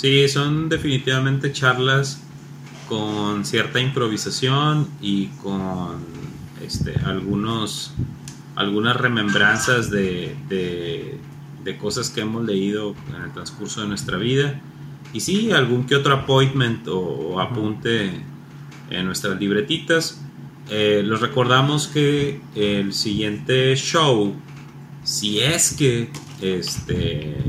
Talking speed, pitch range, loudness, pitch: 105 wpm, 105-145 Hz, -21 LUFS, 130 Hz